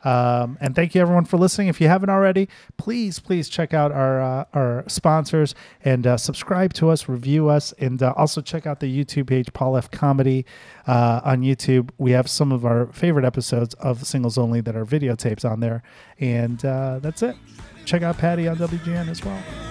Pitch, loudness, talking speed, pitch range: 140 Hz, -21 LUFS, 200 wpm, 125-165 Hz